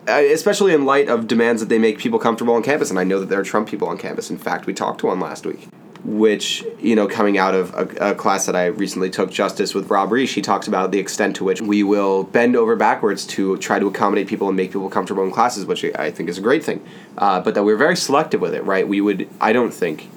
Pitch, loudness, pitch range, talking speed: 105 Hz, -18 LUFS, 95-115 Hz, 270 wpm